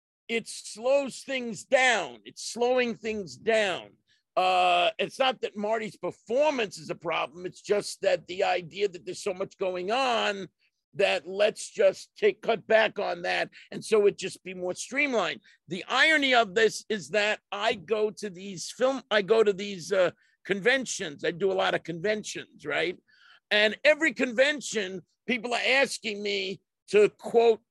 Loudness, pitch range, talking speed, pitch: -27 LUFS, 190-235 Hz, 165 wpm, 210 Hz